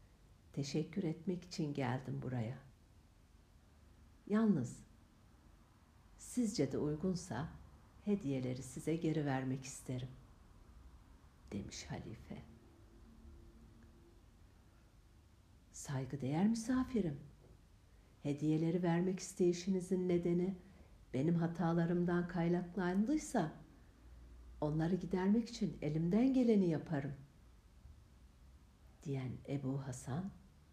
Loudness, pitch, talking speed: -39 LUFS, 135 Hz, 70 wpm